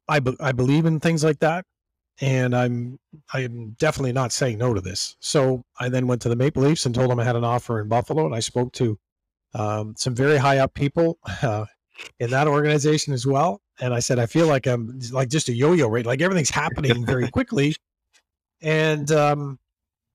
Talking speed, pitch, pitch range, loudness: 210 wpm, 130 Hz, 120-150 Hz, -22 LUFS